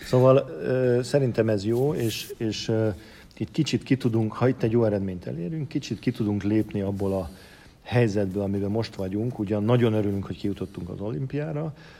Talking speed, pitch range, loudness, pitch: 170 wpm, 100-125 Hz, -26 LUFS, 110 Hz